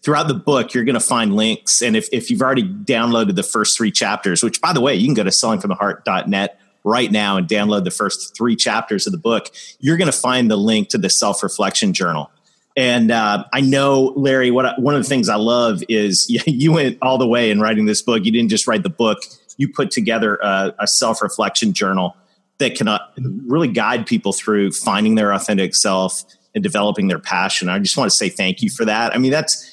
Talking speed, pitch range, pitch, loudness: 225 wpm, 105-140 Hz, 120 Hz, -16 LUFS